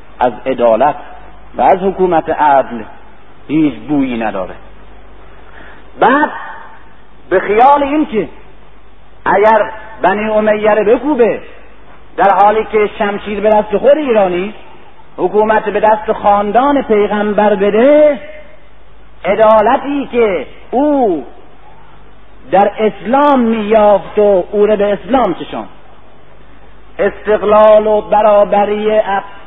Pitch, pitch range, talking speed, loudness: 210 Hz, 205-230 Hz, 95 wpm, -11 LUFS